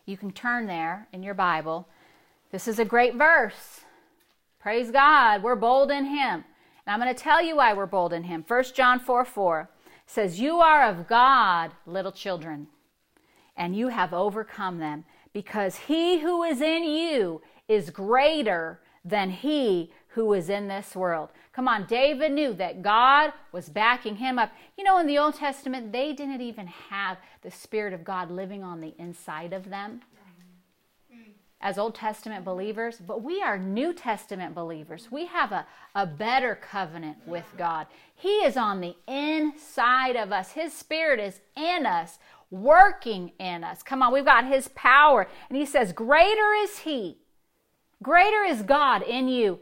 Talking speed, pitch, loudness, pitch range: 170 wpm, 225 Hz, -24 LUFS, 190-280 Hz